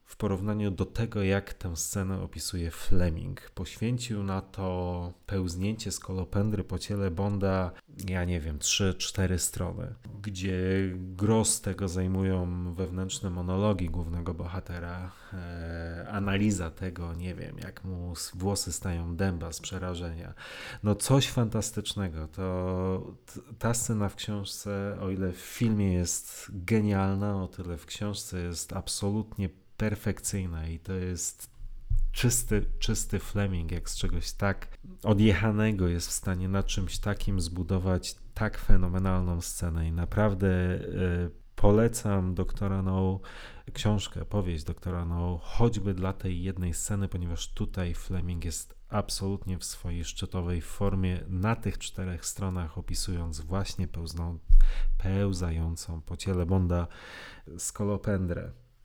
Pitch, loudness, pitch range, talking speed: 95 Hz, -31 LUFS, 90-100 Hz, 120 wpm